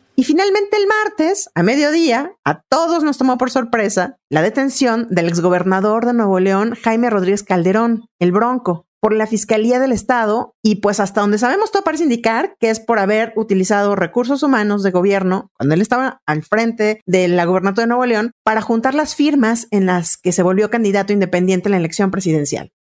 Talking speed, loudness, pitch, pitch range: 190 wpm, -16 LUFS, 220 Hz, 190-250 Hz